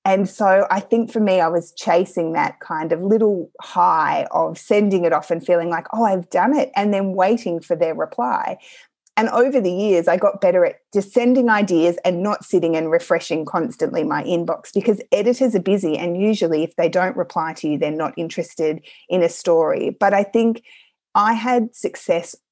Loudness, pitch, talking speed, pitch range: -19 LUFS, 190 Hz, 195 wpm, 170-225 Hz